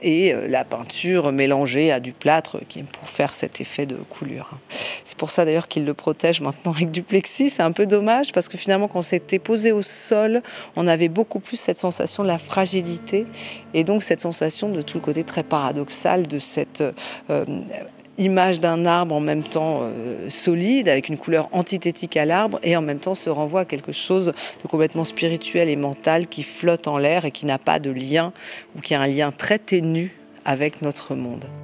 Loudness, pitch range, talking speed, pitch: -22 LUFS, 150-190 Hz, 205 wpm, 170 Hz